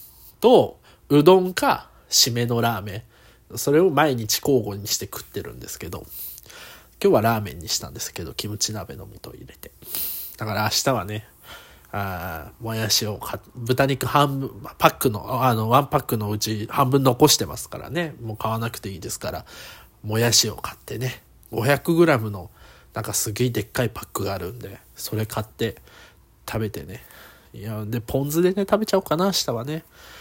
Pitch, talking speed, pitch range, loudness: 115 Hz, 325 characters per minute, 110-135 Hz, -22 LUFS